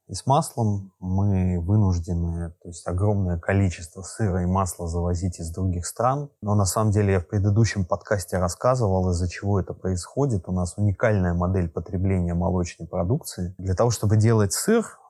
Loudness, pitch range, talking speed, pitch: -24 LUFS, 90-105 Hz, 165 wpm, 95 Hz